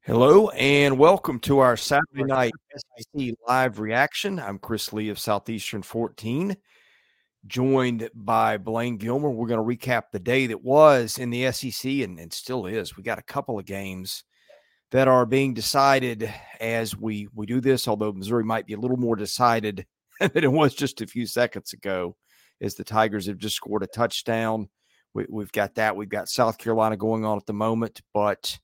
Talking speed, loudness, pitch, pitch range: 185 wpm, -24 LUFS, 115 Hz, 105-130 Hz